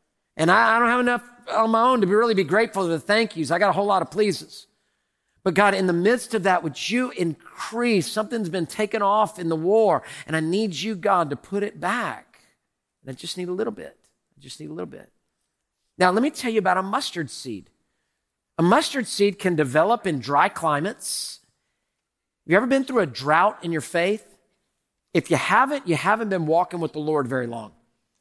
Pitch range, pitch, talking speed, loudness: 165-220 Hz, 195 Hz, 215 wpm, -22 LUFS